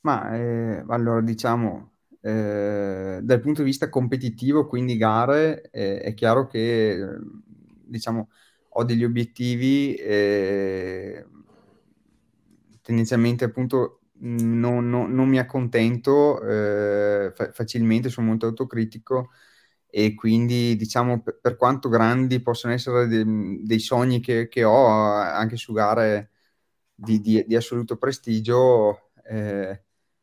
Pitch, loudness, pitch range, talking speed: 115 Hz, -22 LUFS, 110-125 Hz, 115 wpm